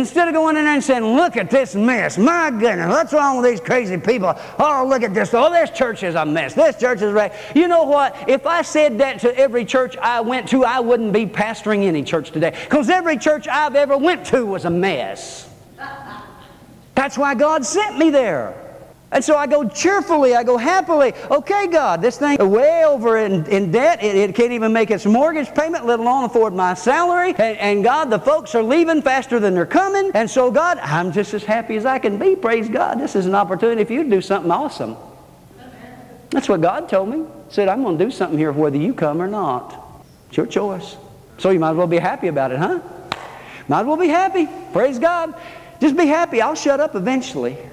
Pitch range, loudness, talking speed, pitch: 205-300 Hz, -17 LUFS, 225 wpm, 250 Hz